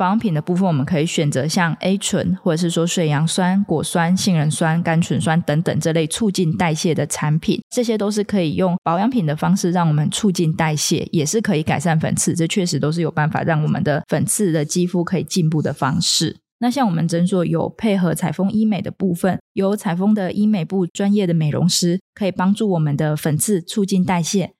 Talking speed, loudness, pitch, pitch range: 330 characters per minute, -19 LUFS, 175 Hz, 160-190 Hz